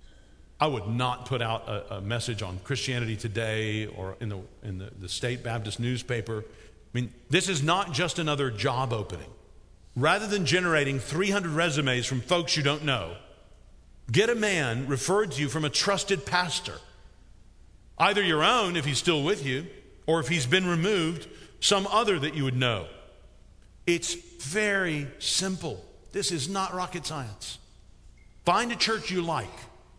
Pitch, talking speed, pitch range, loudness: 140 Hz, 160 wpm, 110-175 Hz, -27 LUFS